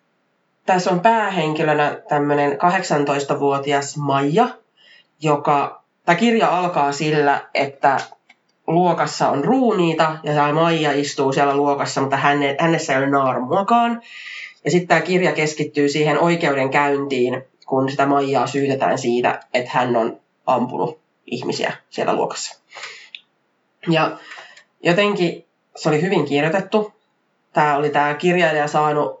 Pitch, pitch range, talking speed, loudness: 150 Hz, 140-175 Hz, 115 wpm, -19 LUFS